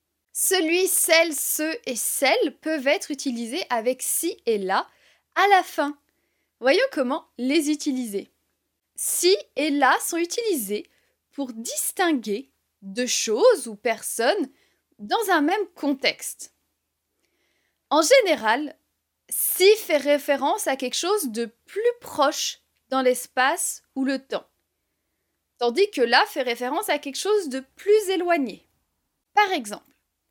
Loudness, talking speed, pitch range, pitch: -23 LUFS, 125 wpm, 255-370 Hz, 300 Hz